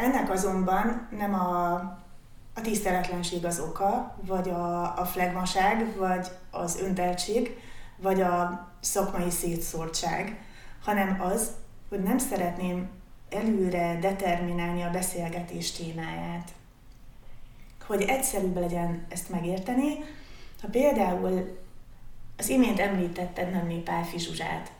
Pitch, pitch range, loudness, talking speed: 180 Hz, 175-195 Hz, -29 LUFS, 100 wpm